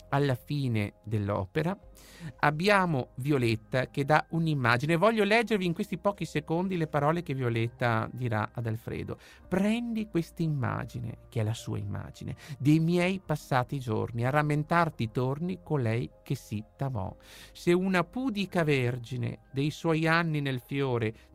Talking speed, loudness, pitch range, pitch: 140 wpm, -29 LUFS, 120-165 Hz, 140 Hz